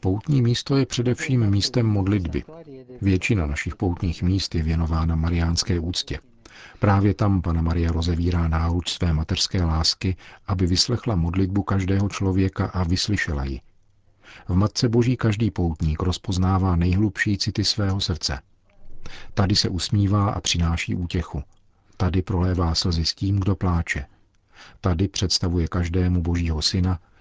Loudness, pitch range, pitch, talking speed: -23 LUFS, 85-100 Hz, 95 Hz, 130 wpm